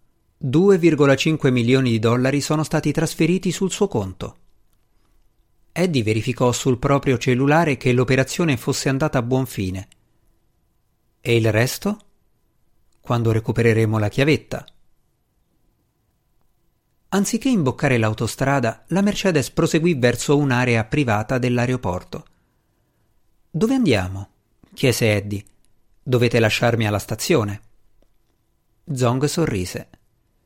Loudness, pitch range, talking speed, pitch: -20 LUFS, 110-145 Hz, 95 wpm, 125 Hz